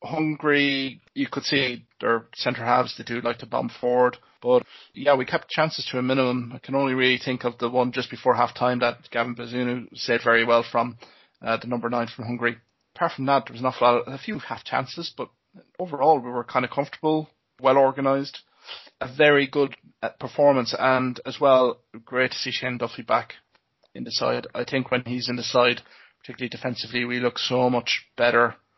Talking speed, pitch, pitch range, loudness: 195 wpm, 125 Hz, 120-135 Hz, -24 LUFS